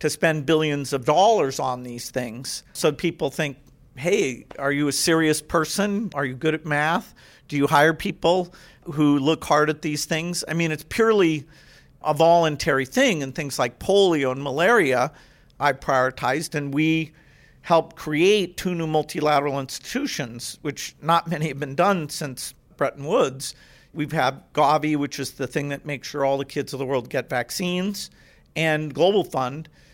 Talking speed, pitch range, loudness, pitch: 170 wpm, 140-165 Hz, -23 LUFS, 150 Hz